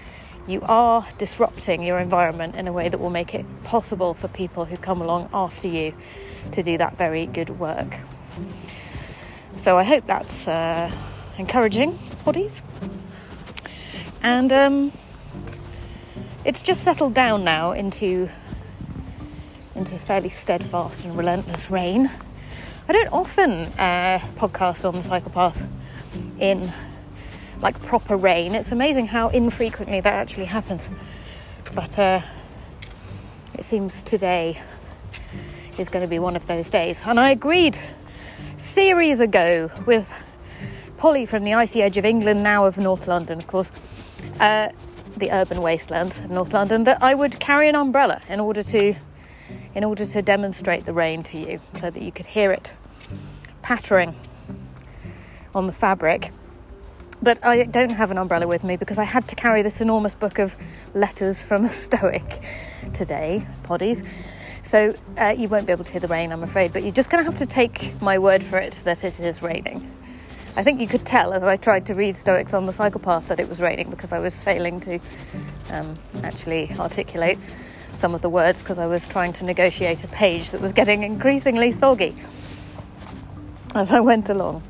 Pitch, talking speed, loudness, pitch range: 190 Hz, 165 wpm, -21 LUFS, 170-220 Hz